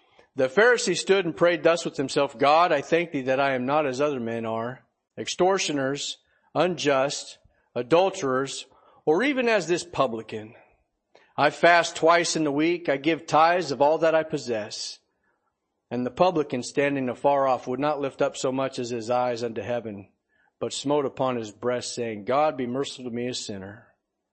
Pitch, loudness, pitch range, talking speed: 140 Hz, -24 LUFS, 125-160 Hz, 180 wpm